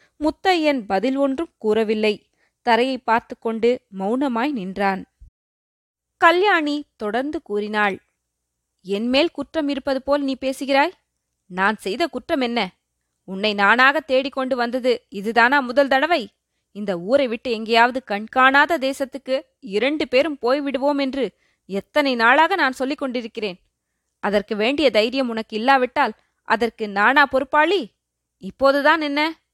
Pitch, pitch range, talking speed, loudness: 250 Hz, 210-280 Hz, 110 wpm, -20 LUFS